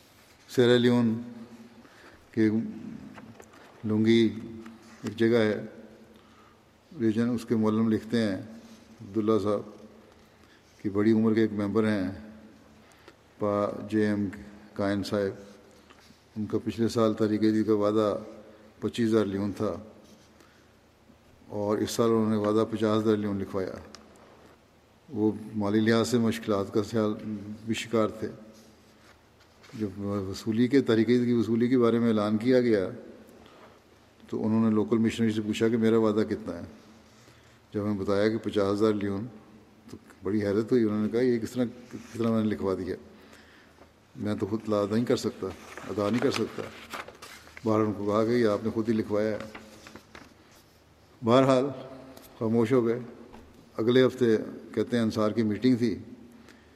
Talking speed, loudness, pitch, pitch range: 145 wpm, -27 LUFS, 110 Hz, 105-115 Hz